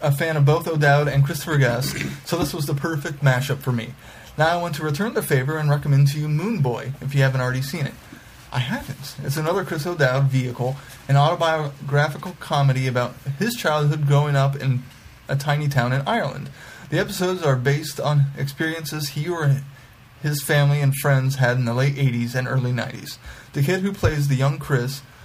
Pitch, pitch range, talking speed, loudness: 140 Hz, 130-150 Hz, 195 wpm, -22 LUFS